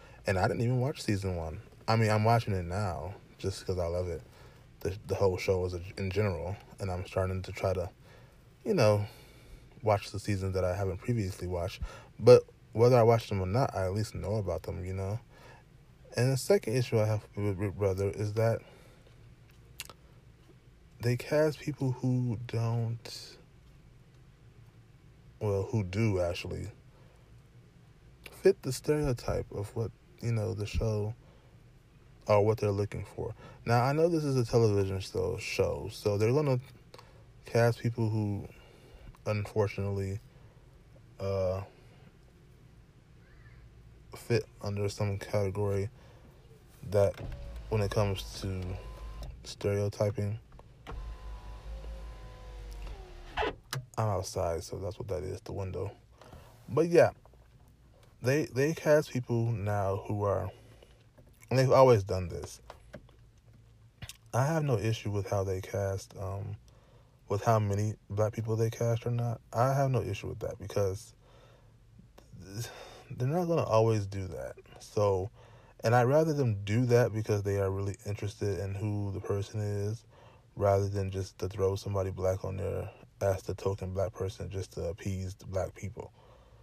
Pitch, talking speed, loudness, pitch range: 110 Hz, 145 wpm, -31 LUFS, 100-120 Hz